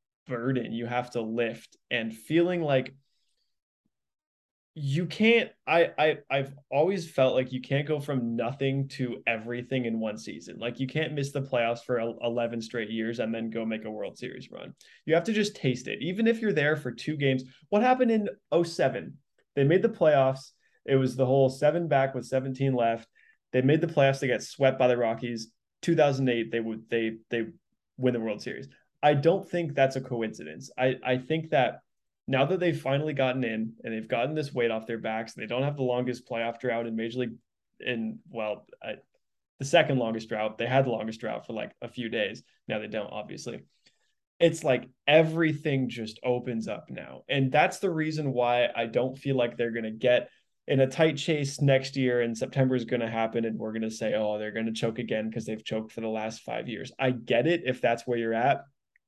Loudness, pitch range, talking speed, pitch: -28 LUFS, 115-140 Hz, 205 wpm, 125 Hz